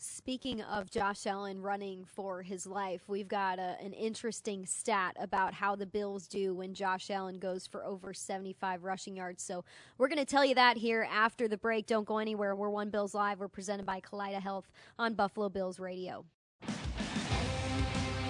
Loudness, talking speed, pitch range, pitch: -35 LUFS, 175 wpm, 190-210 Hz, 200 Hz